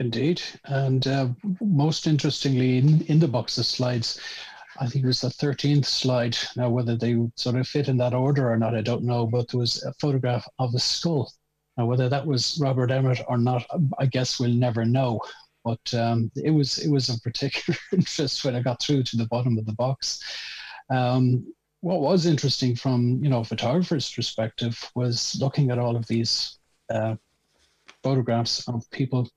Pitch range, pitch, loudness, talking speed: 120-140 Hz, 125 Hz, -24 LUFS, 190 wpm